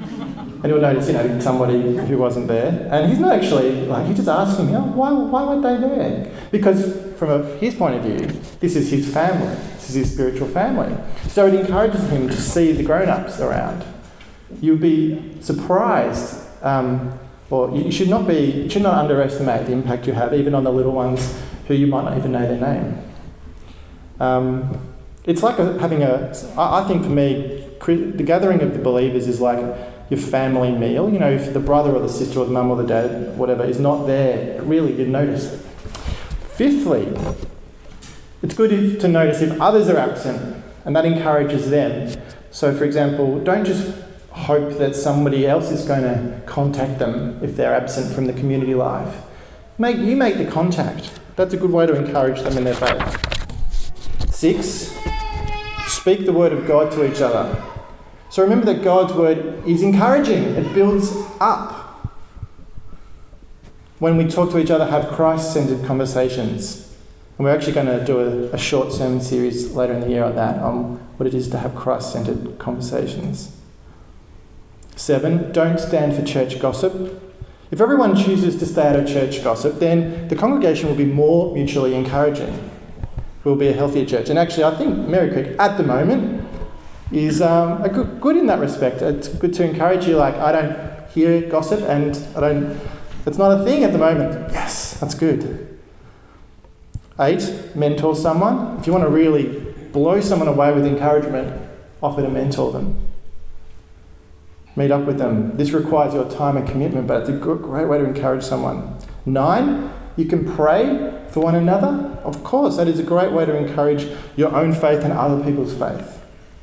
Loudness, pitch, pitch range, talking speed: -19 LUFS, 145 Hz, 130-170 Hz, 180 wpm